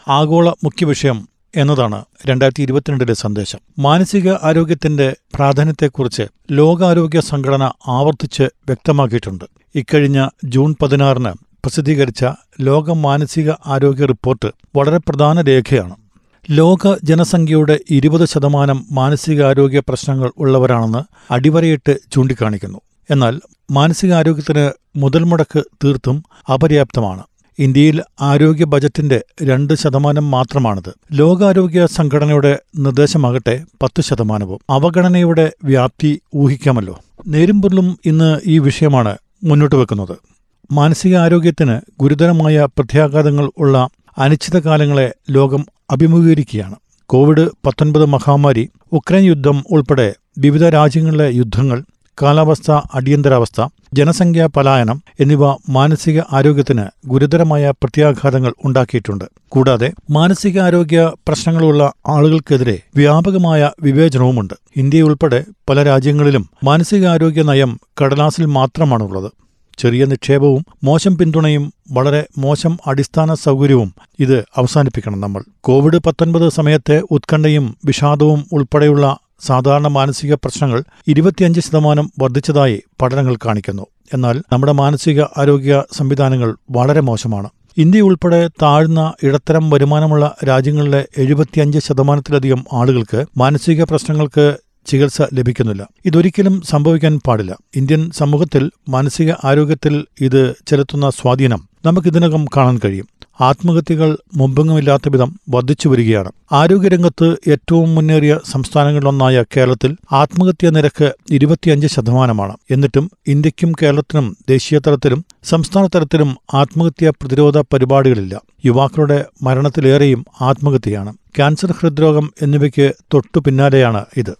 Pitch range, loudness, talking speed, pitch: 130-155 Hz, -13 LUFS, 90 wpm, 145 Hz